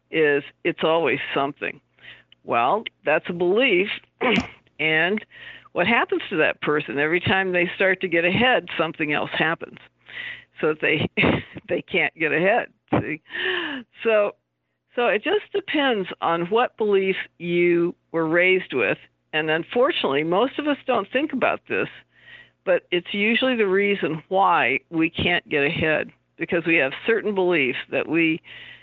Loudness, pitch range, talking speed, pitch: -22 LUFS, 160-245 Hz, 145 wpm, 185 Hz